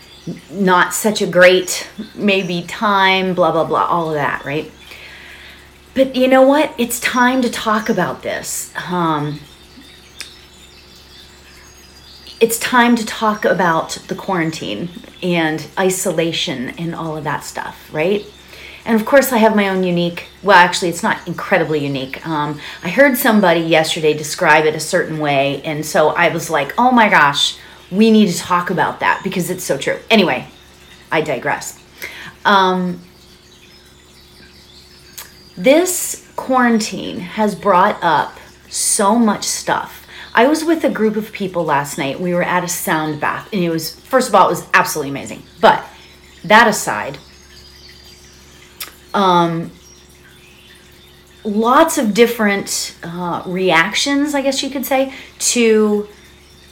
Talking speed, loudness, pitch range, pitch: 140 wpm, -15 LUFS, 135-215 Hz, 175 Hz